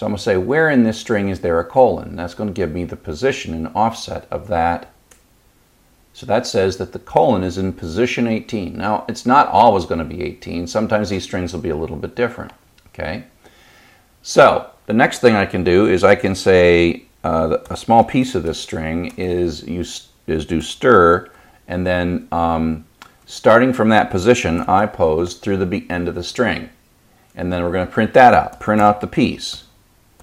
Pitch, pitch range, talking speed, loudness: 90 Hz, 85-105 Hz, 200 wpm, -17 LUFS